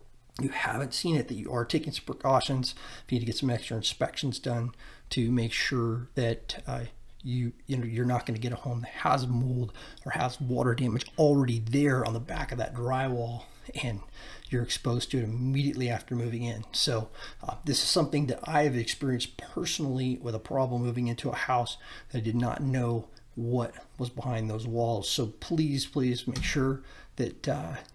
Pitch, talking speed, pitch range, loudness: 125 Hz, 200 wpm, 120-135 Hz, -30 LUFS